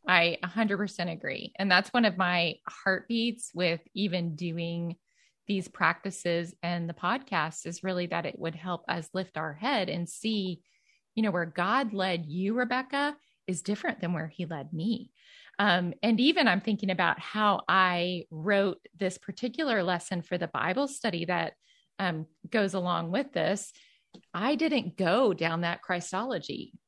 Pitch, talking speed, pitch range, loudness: 185 Hz, 160 wpm, 175-215 Hz, -29 LUFS